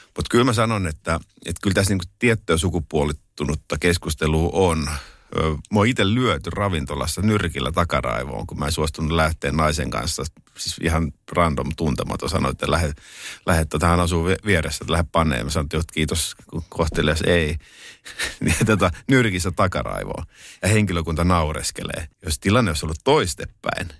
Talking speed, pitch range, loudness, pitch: 150 wpm, 80-95 Hz, -21 LUFS, 85 Hz